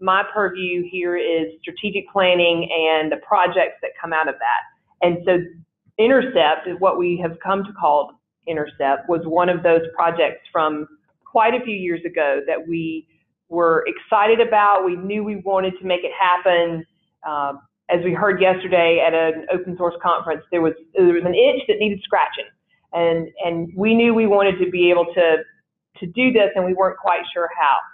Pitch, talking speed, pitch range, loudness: 175 Hz, 185 wpm, 165-195 Hz, -19 LUFS